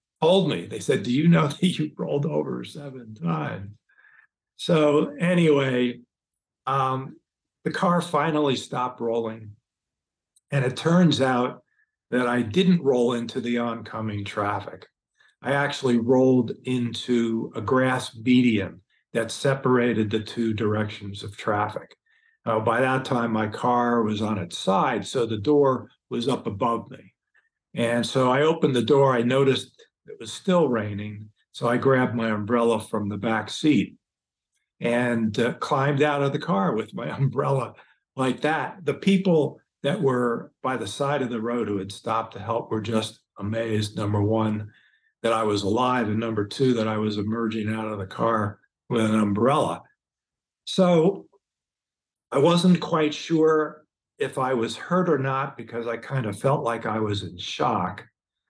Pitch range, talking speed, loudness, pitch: 110-140 Hz, 160 wpm, -24 LUFS, 120 Hz